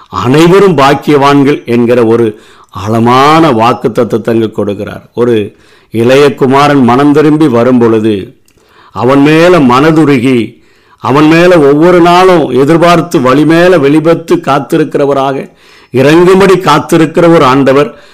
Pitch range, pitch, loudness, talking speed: 120-165 Hz, 140 Hz, -6 LUFS, 105 wpm